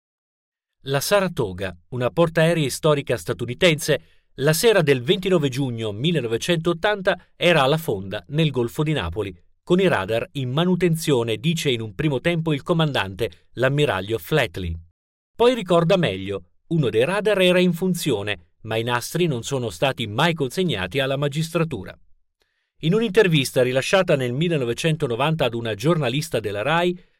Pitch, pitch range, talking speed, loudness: 145 Hz, 115-170 Hz, 135 wpm, -21 LUFS